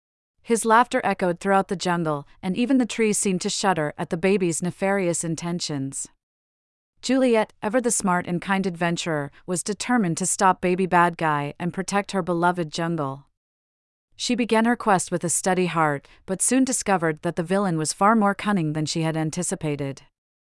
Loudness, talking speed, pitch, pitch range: -23 LUFS, 175 wpm, 180 Hz, 155-200 Hz